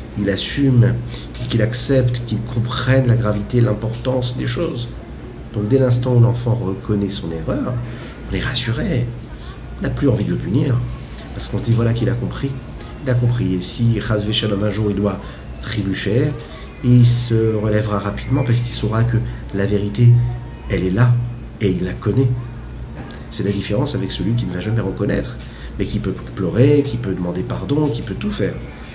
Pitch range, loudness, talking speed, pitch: 100-120 Hz, -19 LUFS, 180 wpm, 115 Hz